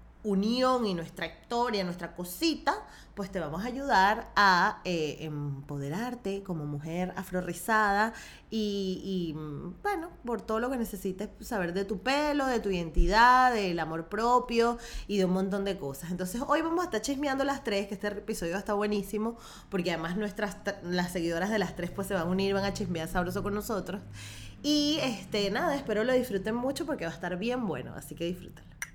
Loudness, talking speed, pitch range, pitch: -30 LUFS, 185 wpm, 175-235 Hz, 200 Hz